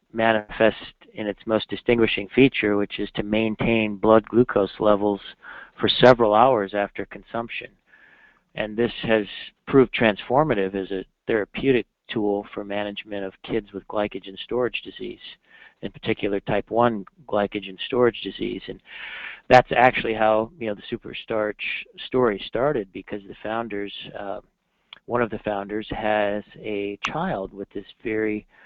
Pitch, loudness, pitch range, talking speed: 105 Hz, -23 LUFS, 100-115 Hz, 140 wpm